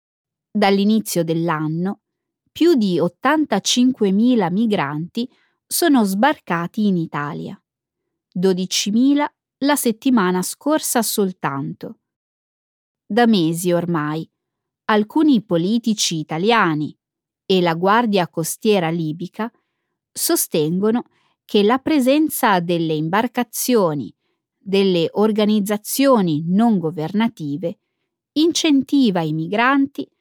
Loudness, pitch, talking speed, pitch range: -18 LUFS, 210 Hz, 75 wpm, 170-245 Hz